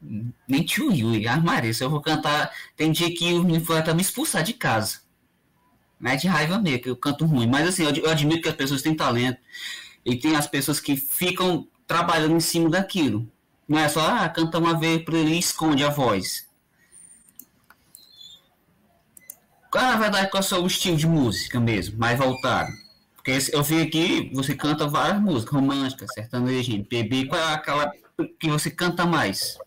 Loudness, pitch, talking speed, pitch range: -23 LUFS, 155 Hz, 190 wpm, 135-170 Hz